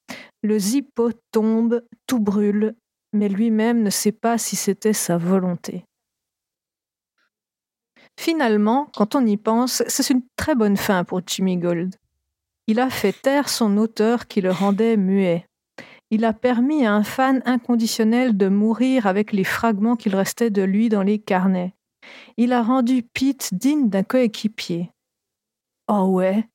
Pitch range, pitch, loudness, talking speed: 195-240 Hz, 220 Hz, -20 LUFS, 145 wpm